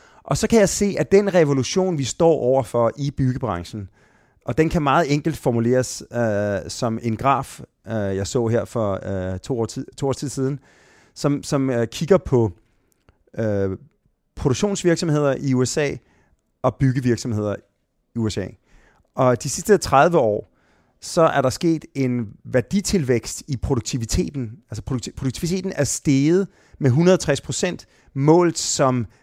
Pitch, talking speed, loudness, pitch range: 130 Hz, 145 wpm, -21 LUFS, 115-155 Hz